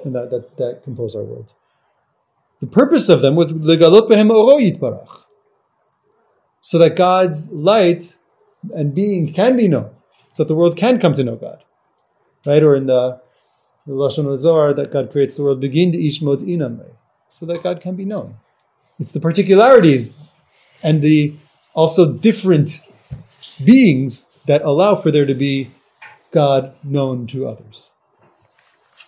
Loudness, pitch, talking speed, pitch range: -14 LUFS, 155 Hz, 140 wpm, 135-180 Hz